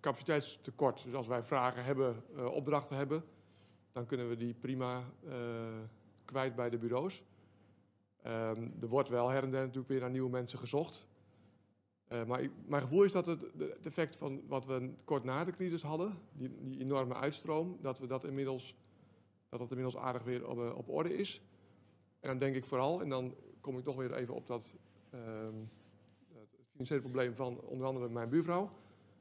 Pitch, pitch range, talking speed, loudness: 130 Hz, 115-140 Hz, 185 wpm, -39 LUFS